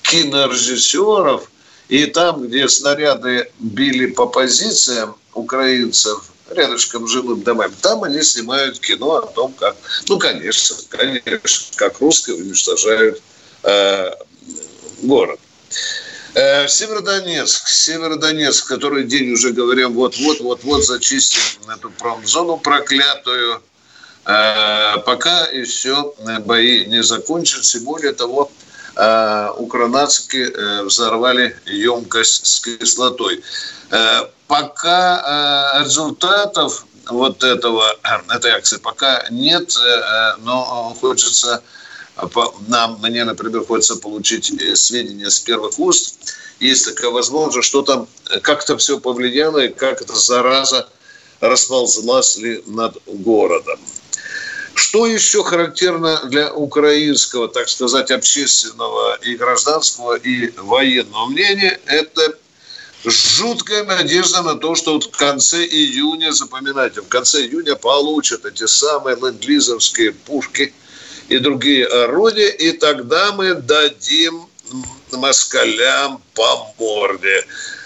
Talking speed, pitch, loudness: 100 wpm, 145 Hz, -14 LUFS